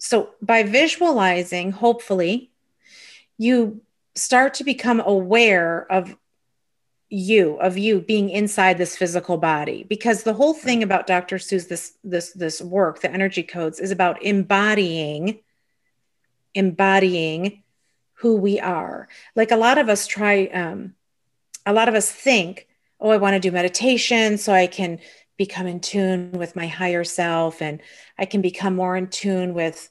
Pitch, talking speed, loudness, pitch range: 195 Hz, 150 wpm, -20 LUFS, 180-220 Hz